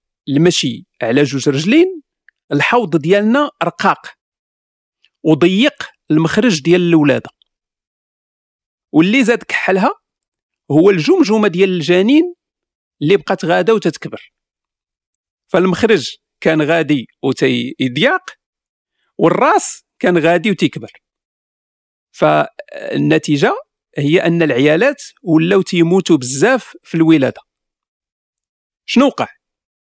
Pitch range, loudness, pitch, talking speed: 150-215 Hz, -14 LUFS, 170 Hz, 80 wpm